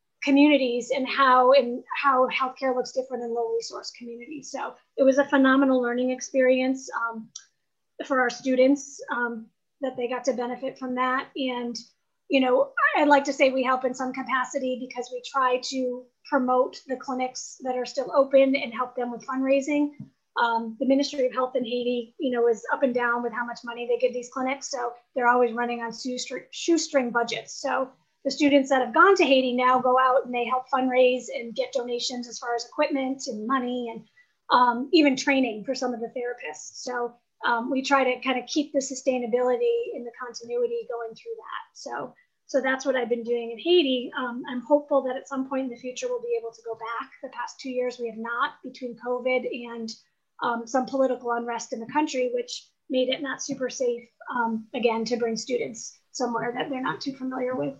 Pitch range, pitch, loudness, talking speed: 240-270 Hz, 255 Hz, -25 LUFS, 205 wpm